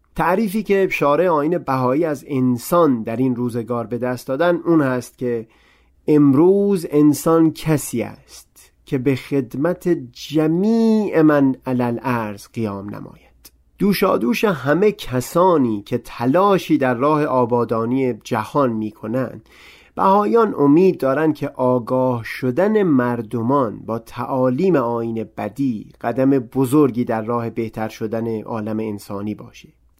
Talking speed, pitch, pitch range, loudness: 120 wpm, 130 Hz, 115-160 Hz, -19 LUFS